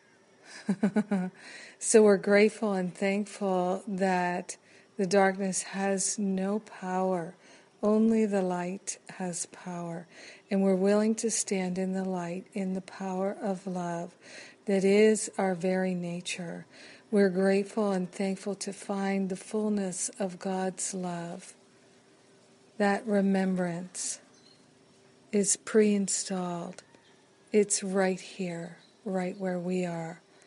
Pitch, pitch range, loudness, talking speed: 195 Hz, 185-205 Hz, -29 LUFS, 110 wpm